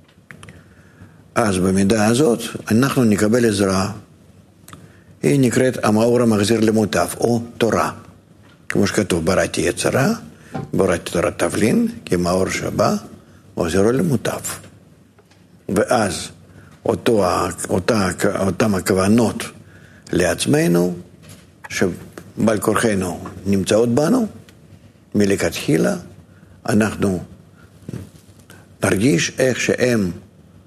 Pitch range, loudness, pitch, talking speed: 90-115 Hz, -18 LUFS, 105 Hz, 75 wpm